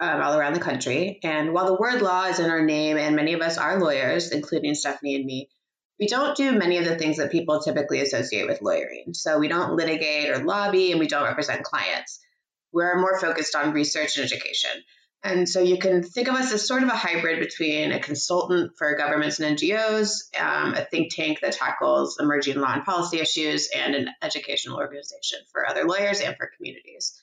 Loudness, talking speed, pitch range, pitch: -24 LUFS, 210 wpm, 150-190 Hz, 165 Hz